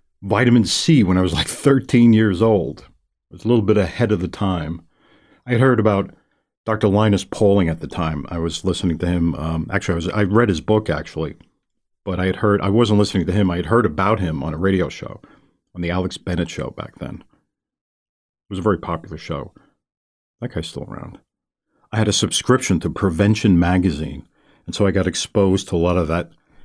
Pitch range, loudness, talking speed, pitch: 85-105 Hz, -19 LUFS, 210 wpm, 95 Hz